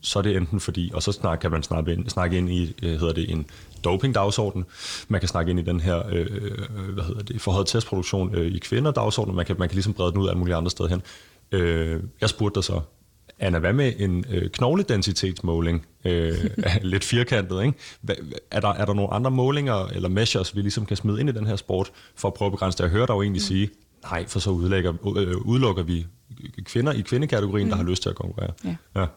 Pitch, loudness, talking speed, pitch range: 100 Hz, -25 LUFS, 210 wpm, 90-105 Hz